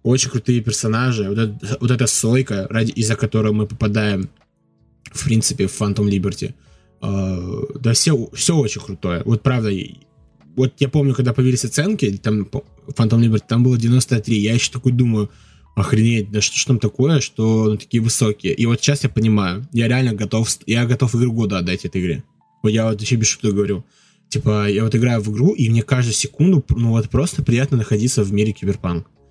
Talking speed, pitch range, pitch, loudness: 190 wpm, 105-130 Hz, 115 Hz, -18 LUFS